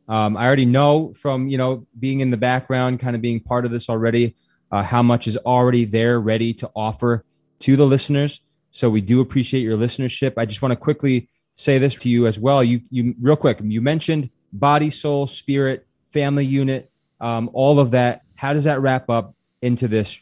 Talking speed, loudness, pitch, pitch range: 205 wpm, -19 LUFS, 125 Hz, 115-140 Hz